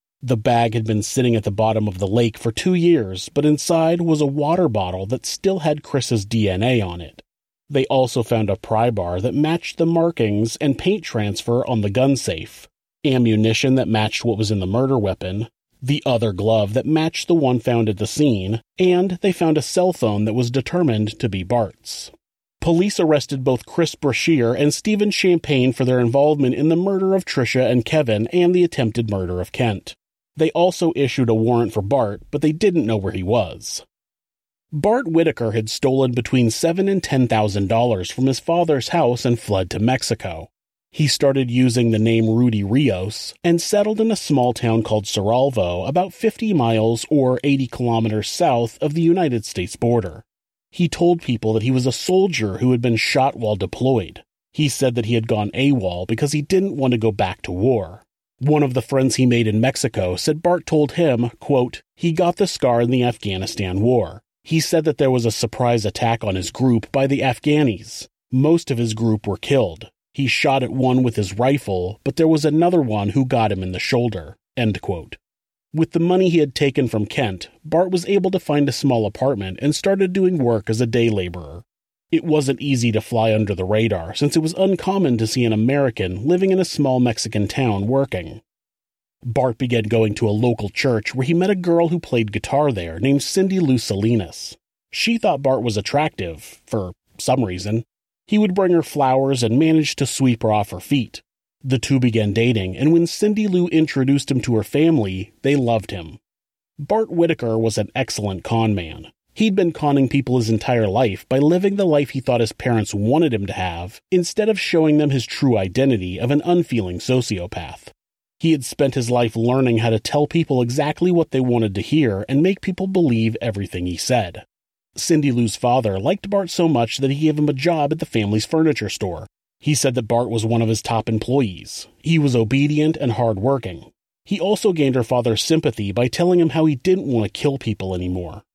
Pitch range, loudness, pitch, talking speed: 110-155 Hz, -19 LUFS, 125 Hz, 200 wpm